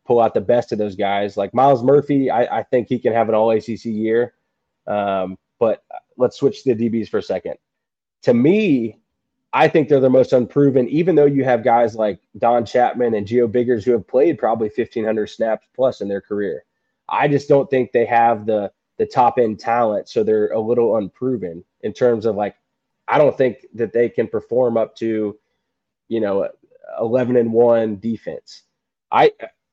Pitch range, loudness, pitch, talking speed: 110-130 Hz, -18 LUFS, 115 Hz, 195 wpm